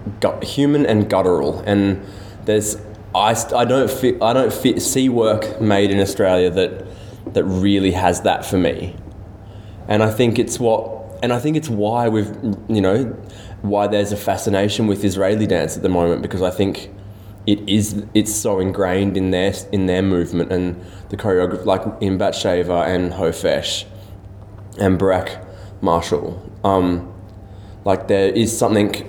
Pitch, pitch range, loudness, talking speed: 100 Hz, 95-105 Hz, -18 LUFS, 160 wpm